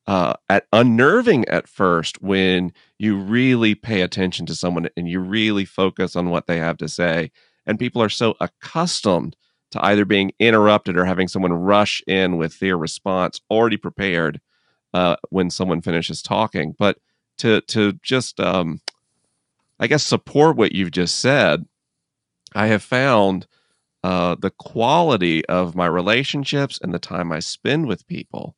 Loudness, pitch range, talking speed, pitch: -19 LUFS, 90-110 Hz, 155 wpm, 95 Hz